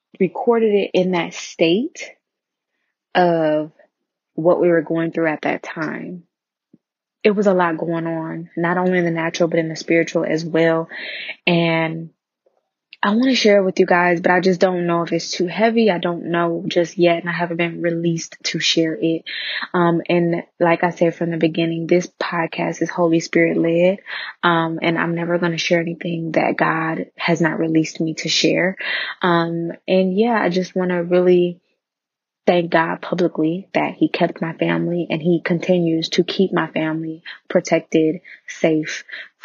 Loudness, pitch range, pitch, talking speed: -19 LUFS, 165-180 Hz, 170 Hz, 180 wpm